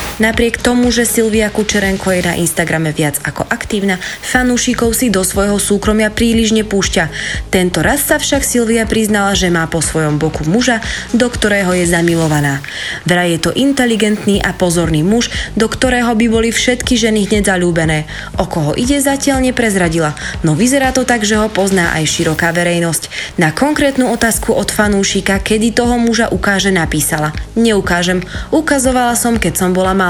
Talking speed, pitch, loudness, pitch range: 160 wpm, 200 Hz, -13 LUFS, 175-235 Hz